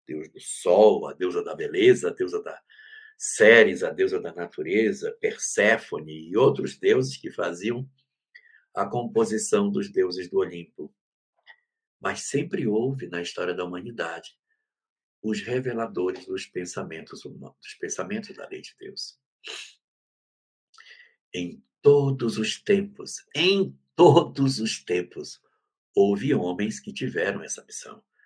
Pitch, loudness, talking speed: 190 Hz, -24 LUFS, 125 wpm